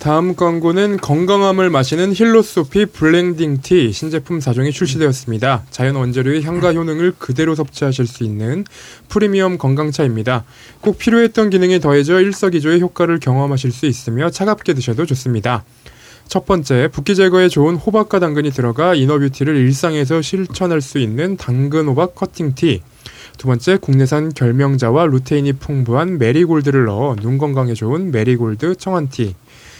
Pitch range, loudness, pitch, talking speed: 130-180 Hz, -15 LUFS, 150 Hz, 360 characters per minute